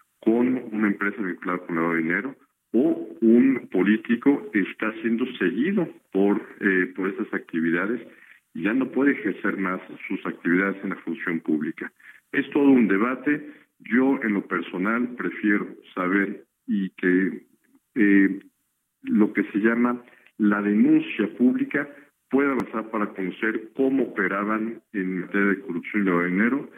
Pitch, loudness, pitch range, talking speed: 105 Hz, -24 LUFS, 95-125 Hz, 140 wpm